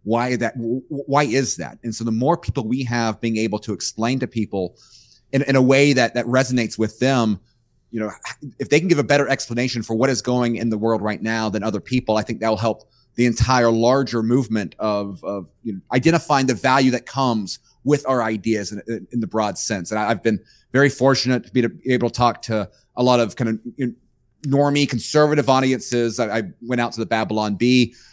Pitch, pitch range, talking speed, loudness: 120 Hz, 110-130 Hz, 220 wpm, -20 LUFS